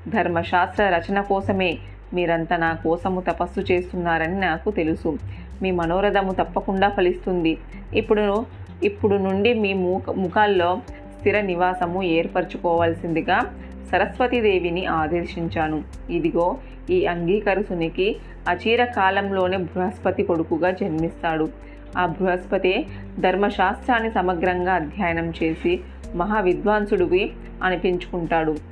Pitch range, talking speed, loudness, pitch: 170-200 Hz, 90 wpm, -22 LUFS, 180 Hz